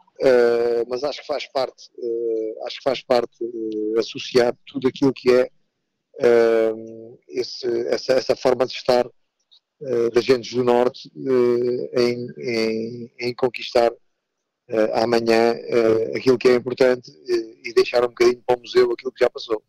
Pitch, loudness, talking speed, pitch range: 125 Hz, -21 LUFS, 160 wpm, 115-135 Hz